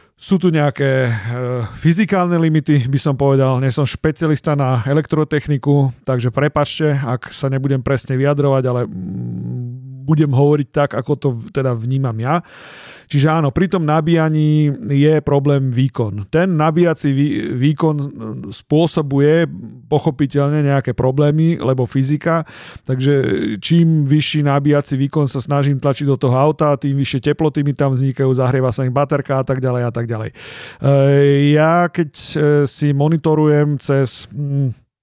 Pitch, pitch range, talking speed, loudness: 140 Hz, 130-150 Hz, 135 wpm, -16 LUFS